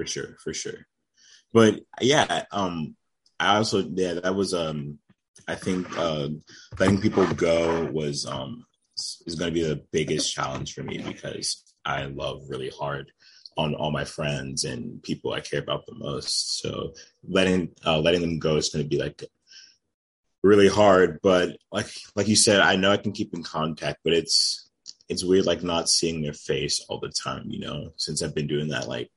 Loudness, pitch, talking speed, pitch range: -25 LUFS, 85 Hz, 185 wpm, 75-95 Hz